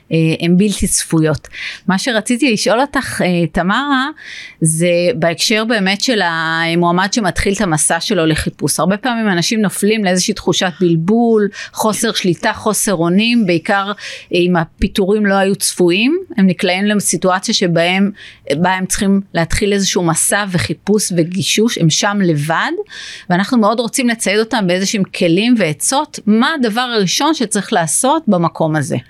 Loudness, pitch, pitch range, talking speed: -14 LUFS, 195 Hz, 175-220 Hz, 130 wpm